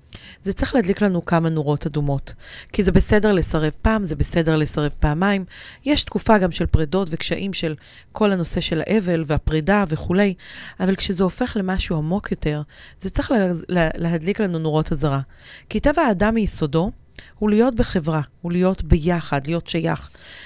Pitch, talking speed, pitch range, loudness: 175 Hz, 155 wpm, 160-205 Hz, -20 LUFS